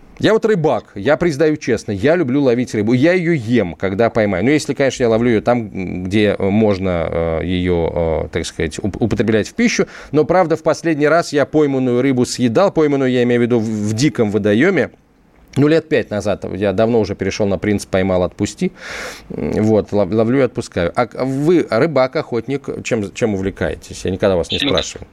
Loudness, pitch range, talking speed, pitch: -16 LUFS, 105-145 Hz, 180 wpm, 120 Hz